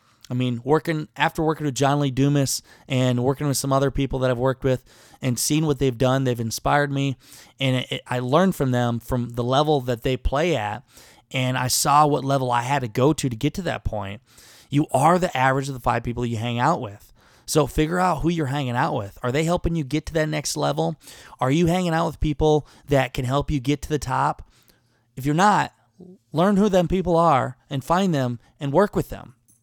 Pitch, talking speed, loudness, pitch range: 140 Hz, 230 wpm, -22 LUFS, 125-155 Hz